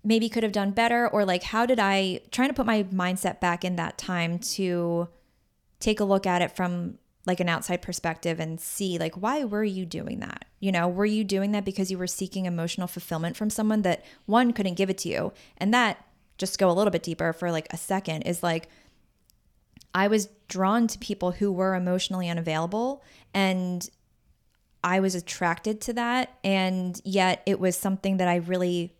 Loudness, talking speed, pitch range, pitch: -27 LUFS, 200 wpm, 175-210 Hz, 190 Hz